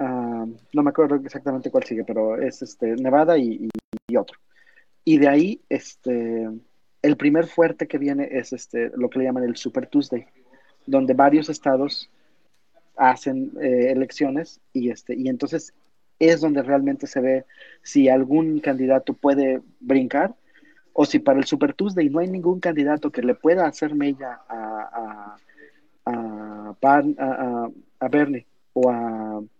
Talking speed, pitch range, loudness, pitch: 160 wpm, 120-150 Hz, -22 LUFS, 135 Hz